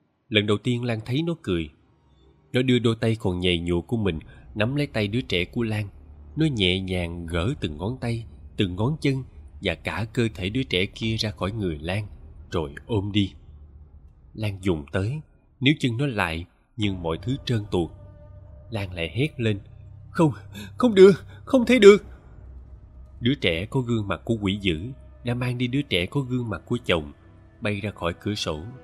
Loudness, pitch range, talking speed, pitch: -24 LUFS, 90-120 Hz, 190 wpm, 105 Hz